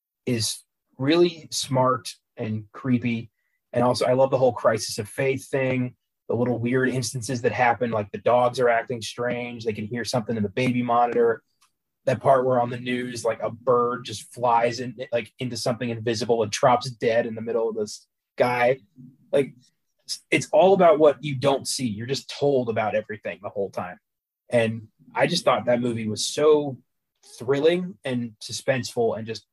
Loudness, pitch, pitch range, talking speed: -24 LUFS, 120 Hz, 115-130 Hz, 180 wpm